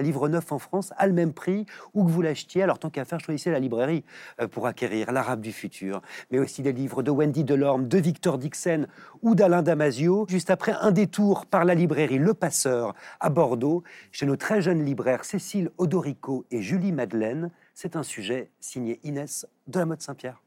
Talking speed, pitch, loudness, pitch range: 195 wpm, 160 Hz, -26 LUFS, 135-180 Hz